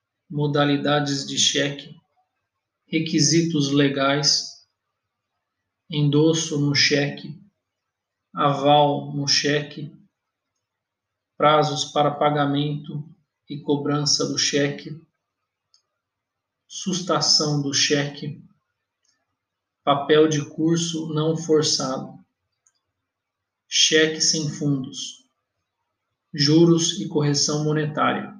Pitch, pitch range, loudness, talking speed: 150 Hz, 140-160 Hz, -20 LUFS, 70 wpm